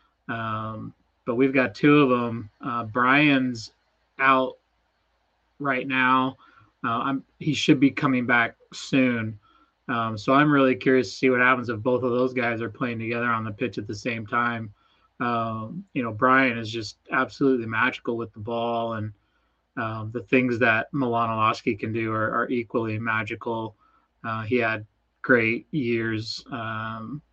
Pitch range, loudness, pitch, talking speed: 110-130 Hz, -24 LUFS, 120 Hz, 160 wpm